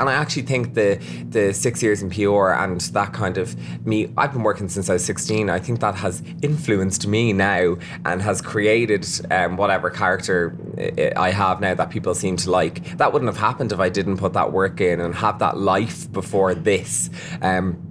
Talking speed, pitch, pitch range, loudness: 200 wpm, 95 Hz, 90-105 Hz, -21 LUFS